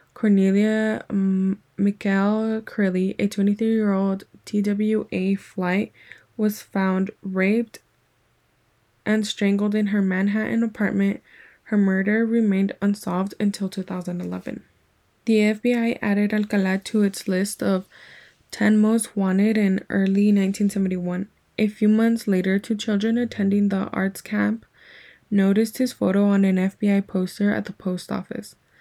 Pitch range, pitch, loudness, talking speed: 195-215 Hz, 200 Hz, -22 LUFS, 120 wpm